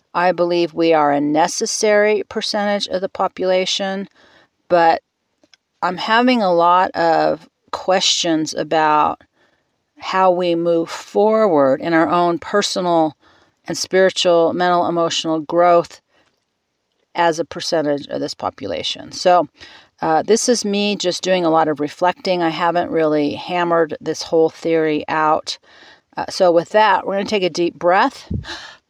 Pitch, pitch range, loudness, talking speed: 175 Hz, 160-190 Hz, -17 LUFS, 140 wpm